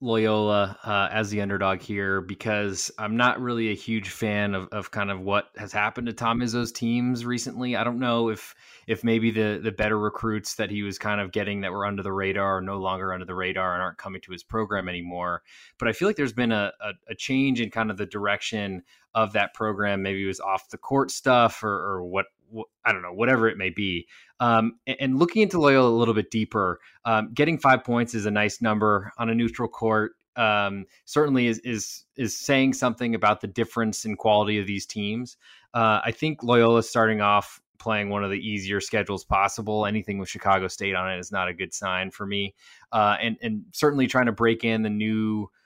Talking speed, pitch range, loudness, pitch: 220 wpm, 100-115 Hz, -25 LUFS, 110 Hz